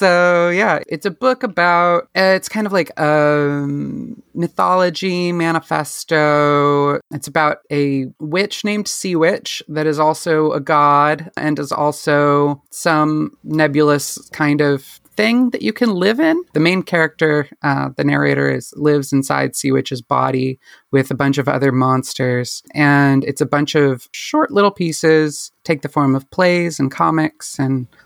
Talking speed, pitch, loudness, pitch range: 155 wpm, 150 Hz, -16 LUFS, 145-175 Hz